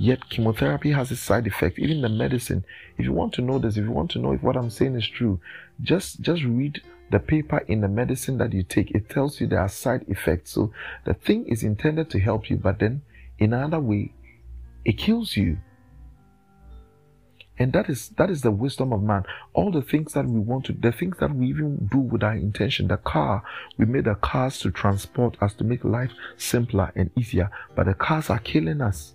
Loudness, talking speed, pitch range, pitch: -24 LUFS, 220 wpm, 100-135 Hz, 120 Hz